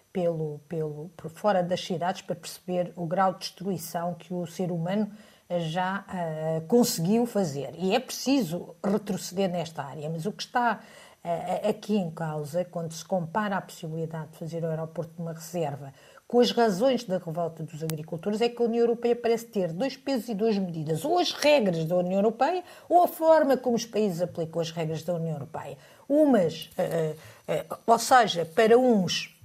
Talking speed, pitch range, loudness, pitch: 190 wpm, 165-225 Hz, -27 LUFS, 180 Hz